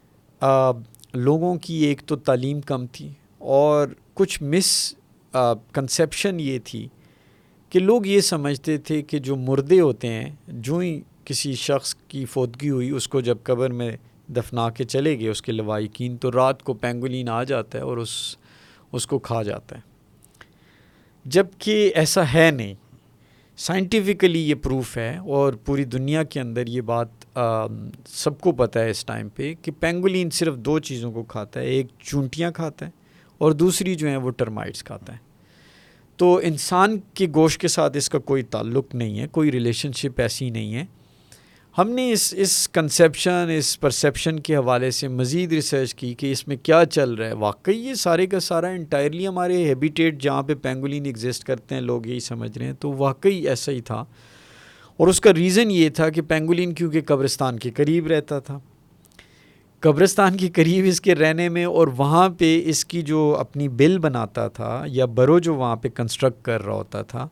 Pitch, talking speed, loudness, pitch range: 140 Hz, 180 wpm, -21 LUFS, 125-165 Hz